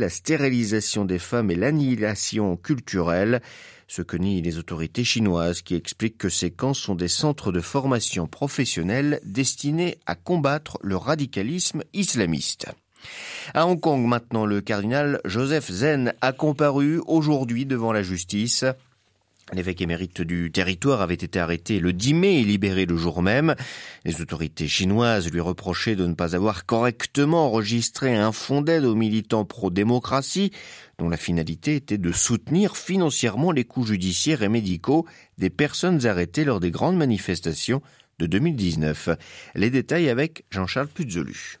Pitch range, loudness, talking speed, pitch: 90-140 Hz, -23 LUFS, 145 wpm, 115 Hz